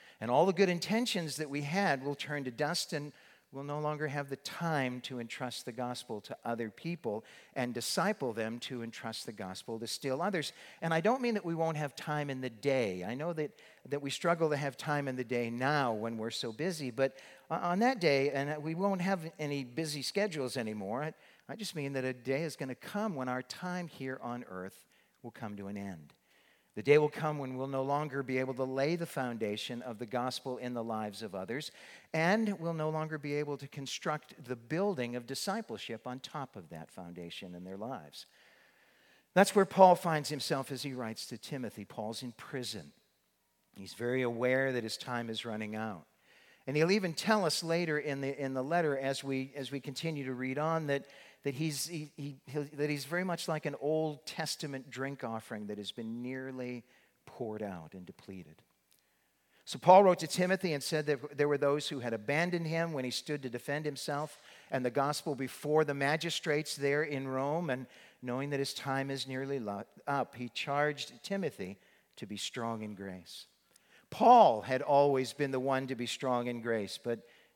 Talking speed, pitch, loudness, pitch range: 205 wpm, 140 Hz, -34 LUFS, 125-155 Hz